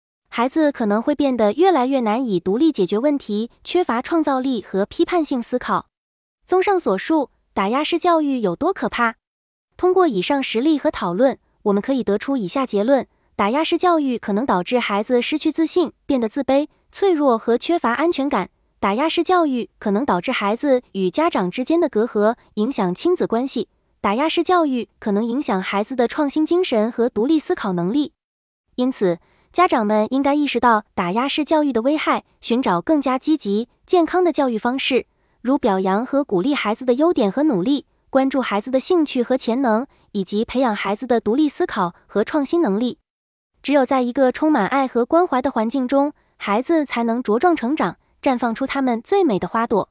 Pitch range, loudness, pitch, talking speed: 220-305 Hz, -19 LUFS, 260 Hz, 290 characters per minute